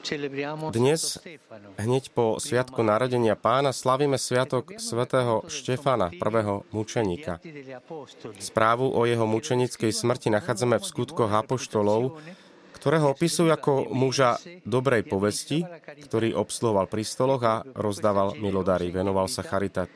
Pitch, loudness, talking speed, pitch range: 120 Hz, -25 LUFS, 110 wpm, 105-135 Hz